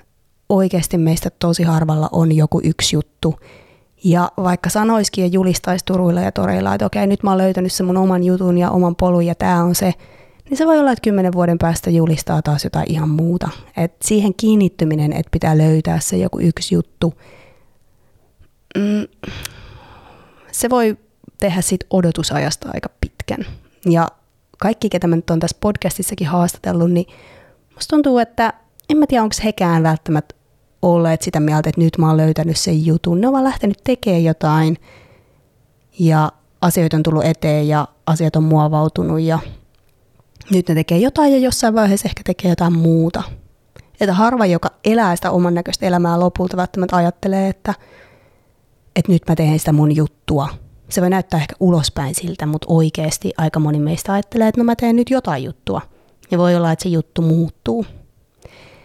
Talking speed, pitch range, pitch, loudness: 170 wpm, 155-190 Hz, 170 Hz, -16 LUFS